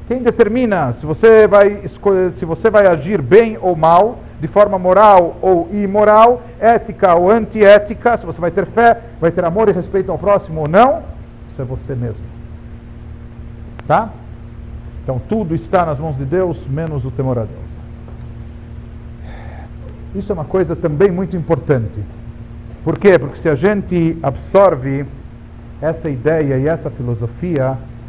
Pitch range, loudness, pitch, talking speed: 135-200 Hz, -14 LUFS, 170 Hz, 150 wpm